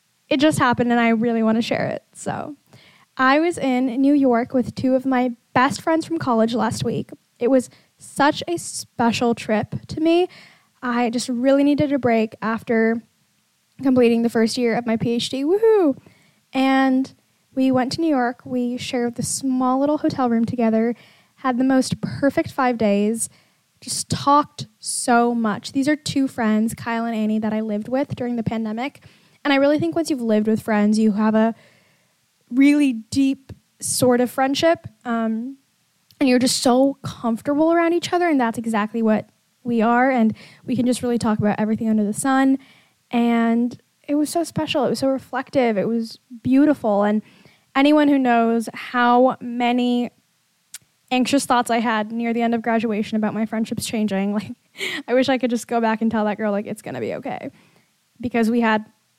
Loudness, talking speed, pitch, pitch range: -20 LUFS, 185 wpm, 245 Hz, 225-270 Hz